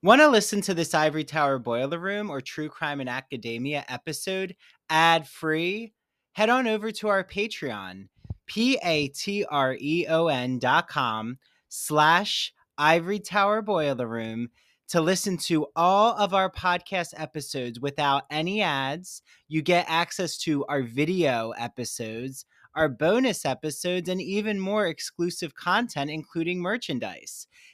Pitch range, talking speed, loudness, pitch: 140-195 Hz, 125 wpm, -26 LUFS, 160 Hz